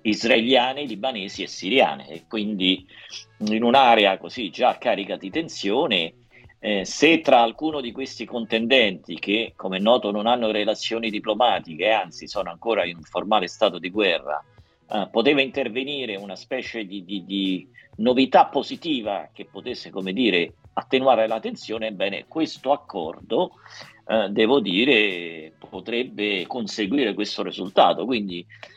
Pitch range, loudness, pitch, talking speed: 105-130 Hz, -22 LUFS, 110 Hz, 130 wpm